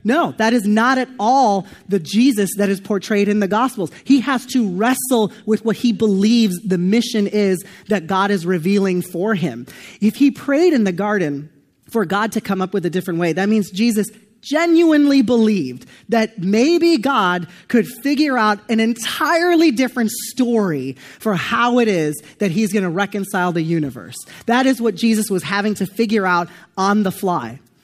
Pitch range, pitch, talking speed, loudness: 185-235 Hz, 210 Hz, 180 wpm, -17 LUFS